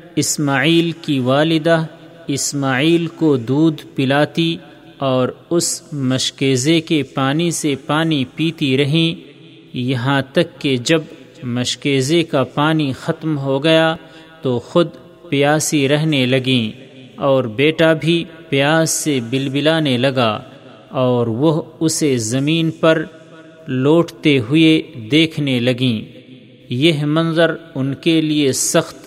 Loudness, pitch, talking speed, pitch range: -16 LUFS, 150 Hz, 110 wpm, 135-160 Hz